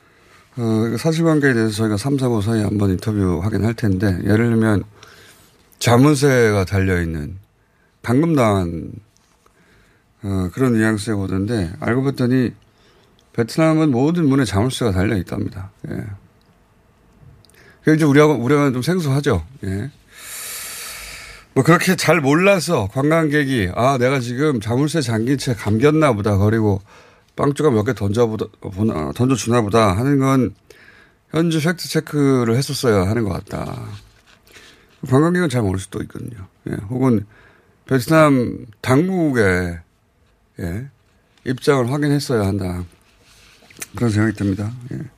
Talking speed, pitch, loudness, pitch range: 260 characters per minute, 115 Hz, -18 LUFS, 105-140 Hz